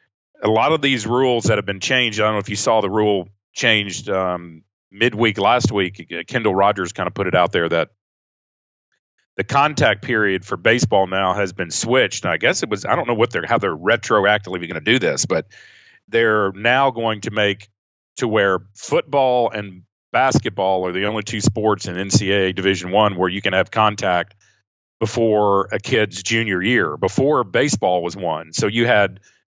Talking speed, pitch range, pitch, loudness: 190 wpm, 95-115 Hz, 105 Hz, -18 LUFS